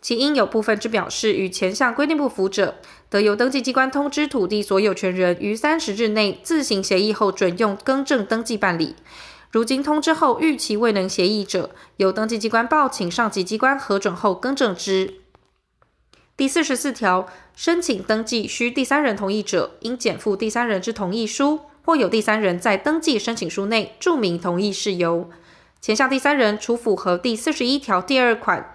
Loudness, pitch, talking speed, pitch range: -20 LUFS, 220 Hz, 285 characters per minute, 195-265 Hz